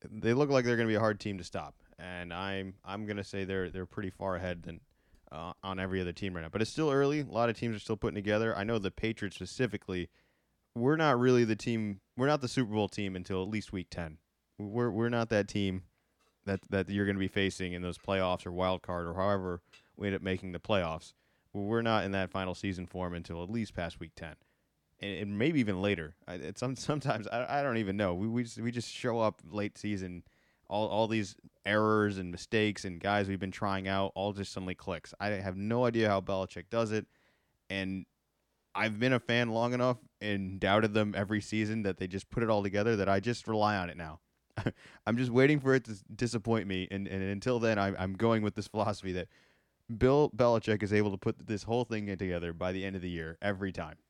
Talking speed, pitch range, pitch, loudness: 225 wpm, 95-110 Hz, 100 Hz, -33 LUFS